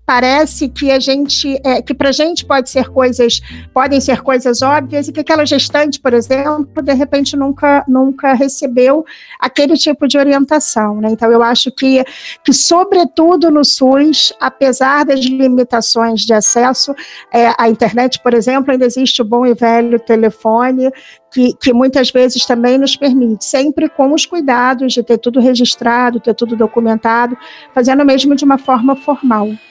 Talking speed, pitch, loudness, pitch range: 165 wpm, 265 Hz, -11 LUFS, 245-280 Hz